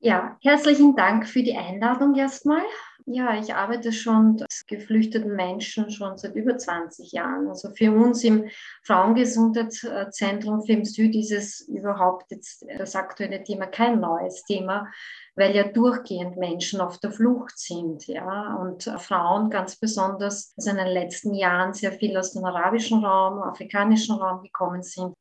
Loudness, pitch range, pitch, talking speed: -23 LUFS, 190-230 Hz, 205 Hz, 150 wpm